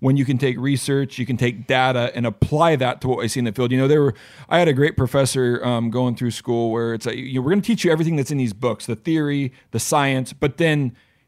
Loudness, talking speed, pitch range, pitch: -20 LUFS, 275 wpm, 120-140 Hz, 130 Hz